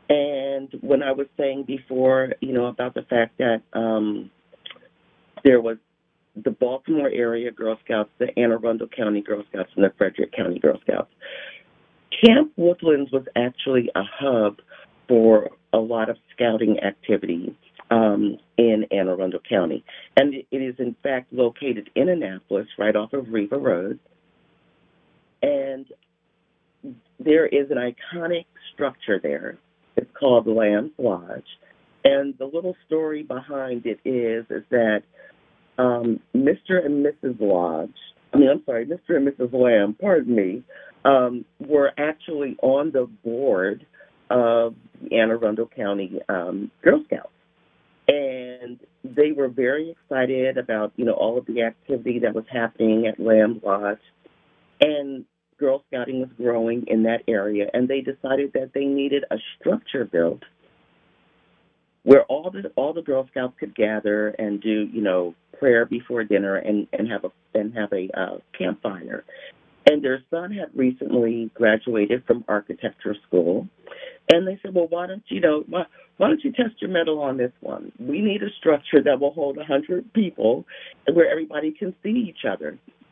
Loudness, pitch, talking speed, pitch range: -22 LUFS, 130 Hz, 155 wpm, 115-145 Hz